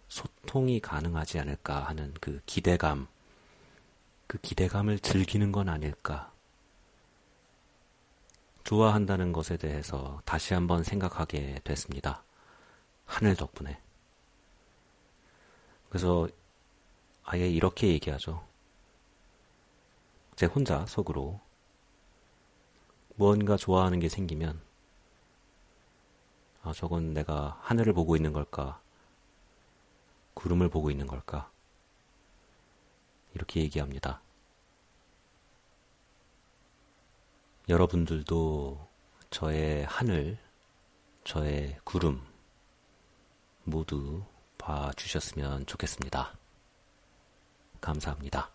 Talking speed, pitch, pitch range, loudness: 180 characters per minute, 80 Hz, 75-95 Hz, -31 LUFS